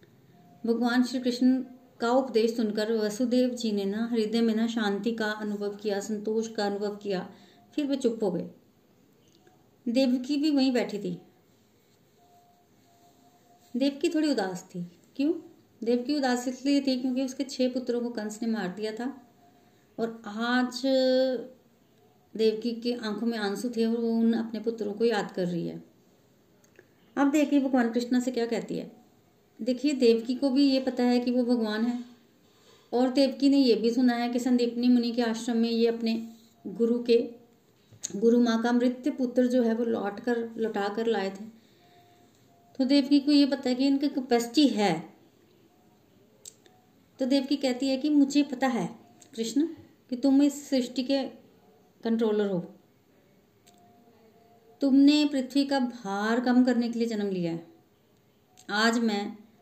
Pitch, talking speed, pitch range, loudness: 235 Hz, 160 wpm, 220-260 Hz, -27 LUFS